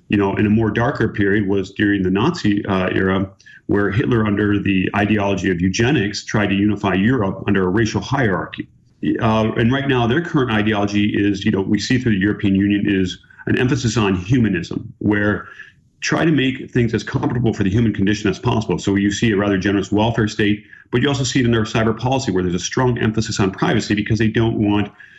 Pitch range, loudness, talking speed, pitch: 100-115 Hz, -18 LUFS, 215 wpm, 105 Hz